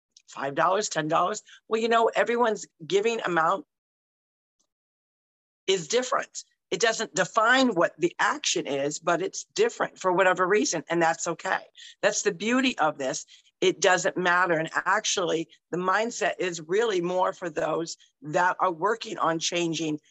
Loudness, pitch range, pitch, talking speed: -25 LUFS, 165-230 Hz, 185 Hz, 145 wpm